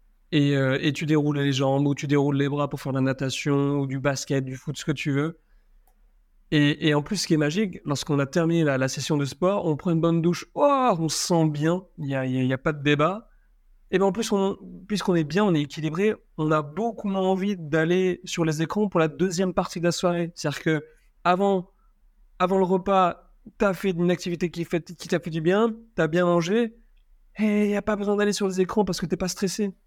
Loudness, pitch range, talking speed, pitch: -24 LUFS, 150-195 Hz, 250 wpm, 175 Hz